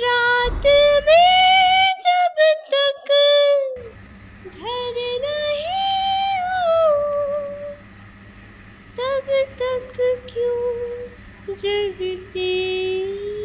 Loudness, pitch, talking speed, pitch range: -18 LUFS, 375 Hz, 50 wpm, 310-485 Hz